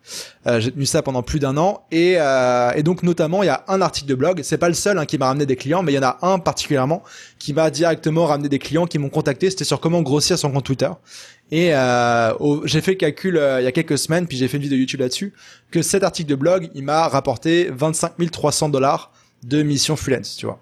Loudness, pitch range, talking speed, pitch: -19 LUFS, 135-170 Hz, 260 wpm, 150 Hz